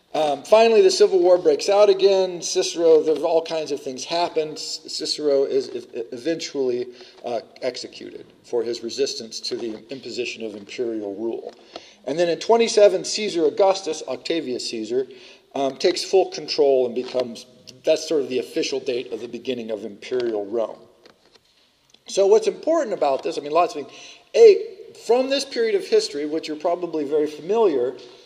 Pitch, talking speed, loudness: 210 Hz, 160 wpm, -21 LUFS